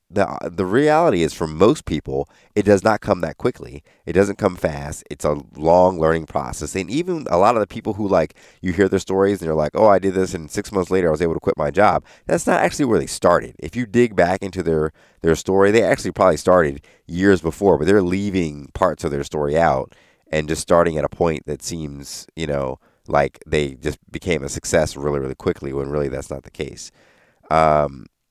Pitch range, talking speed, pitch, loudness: 75-95 Hz, 225 wpm, 80 Hz, -19 LUFS